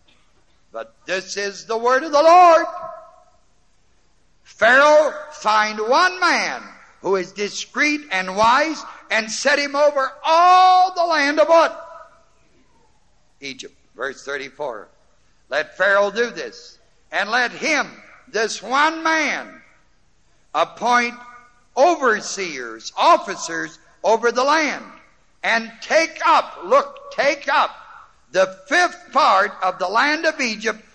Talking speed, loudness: 110 wpm, -18 LUFS